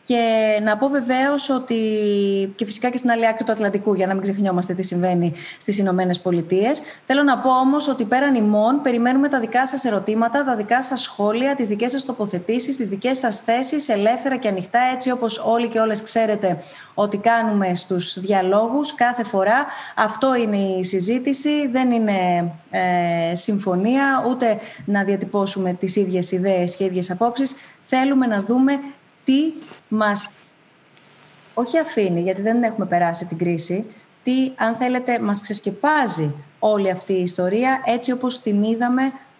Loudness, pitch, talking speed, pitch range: -20 LUFS, 220 Hz, 160 wpm, 195-255 Hz